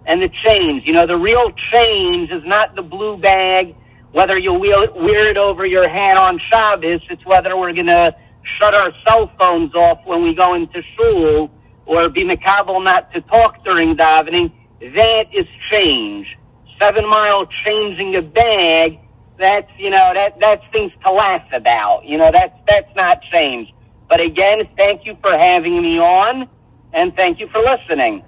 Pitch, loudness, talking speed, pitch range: 200 Hz, -13 LUFS, 170 wpm, 175-295 Hz